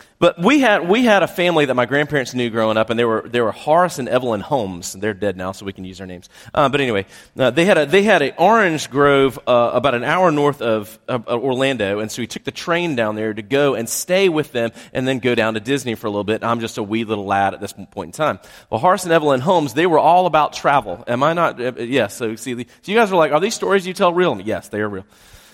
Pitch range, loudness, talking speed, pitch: 110-160 Hz, -17 LUFS, 280 wpm, 125 Hz